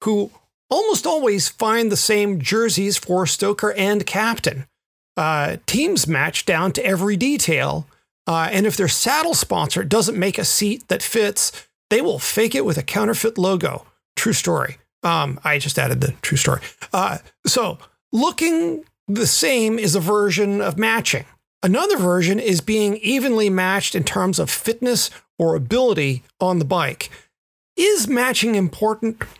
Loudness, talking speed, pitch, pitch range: -19 LUFS, 155 wpm, 205 Hz, 180-225 Hz